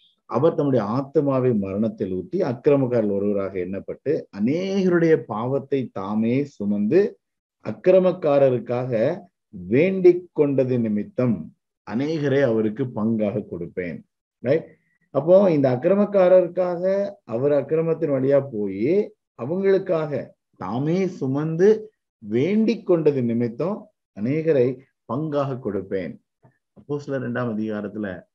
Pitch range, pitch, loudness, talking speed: 115-175 Hz, 140 Hz, -22 LUFS, 85 wpm